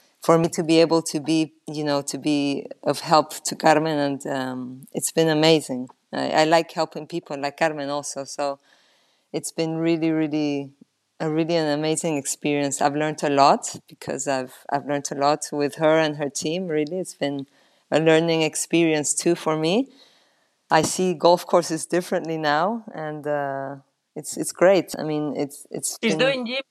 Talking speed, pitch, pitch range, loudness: 175 wpm, 155 Hz, 145-165 Hz, -22 LUFS